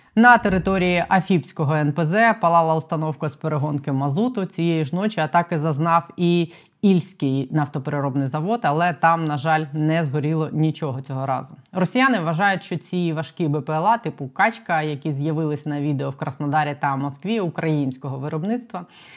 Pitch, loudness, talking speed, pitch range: 160 Hz, -21 LUFS, 140 wpm, 150-180 Hz